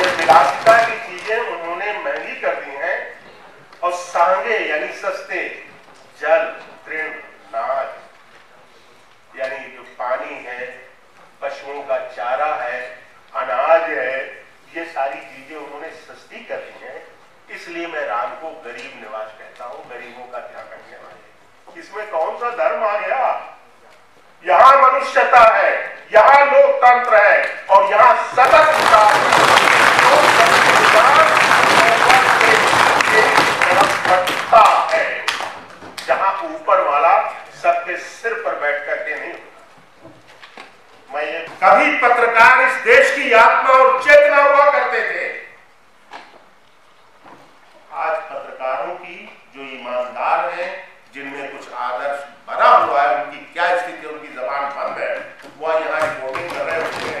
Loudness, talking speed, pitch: -14 LUFS, 120 wpm, 170 Hz